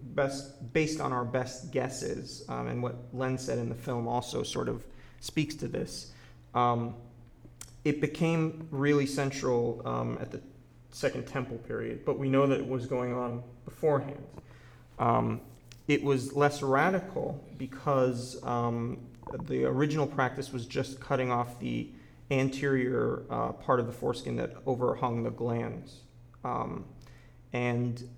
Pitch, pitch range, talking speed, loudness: 125 Hz, 120-140 Hz, 145 wpm, -32 LUFS